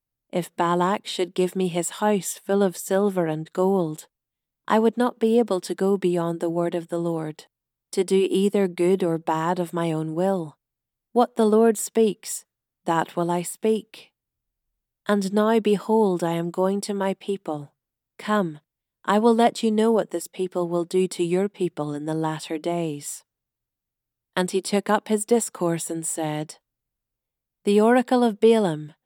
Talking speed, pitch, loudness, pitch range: 170 wpm, 180 Hz, -23 LUFS, 160-205 Hz